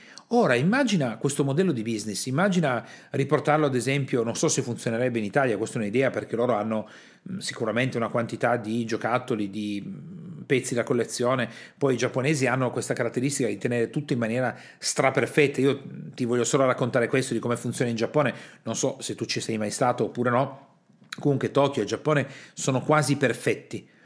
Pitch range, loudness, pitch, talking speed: 115-145 Hz, -25 LUFS, 130 Hz, 175 wpm